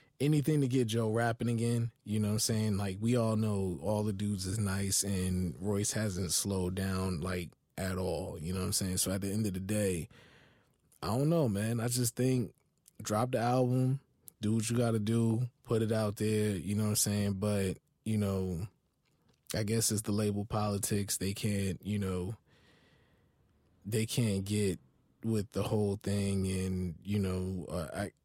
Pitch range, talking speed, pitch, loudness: 95-115 Hz, 190 wpm, 105 Hz, -33 LUFS